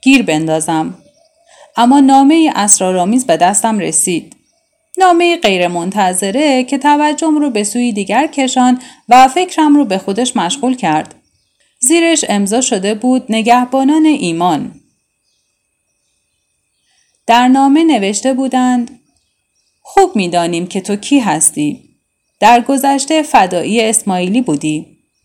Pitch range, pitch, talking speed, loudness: 200-290 Hz, 250 Hz, 110 wpm, -11 LUFS